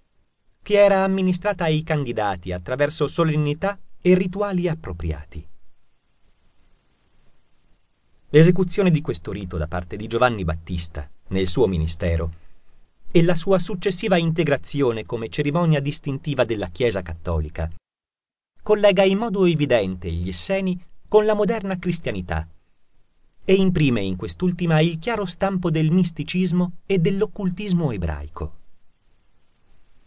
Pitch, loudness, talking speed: 140 Hz, -22 LUFS, 110 wpm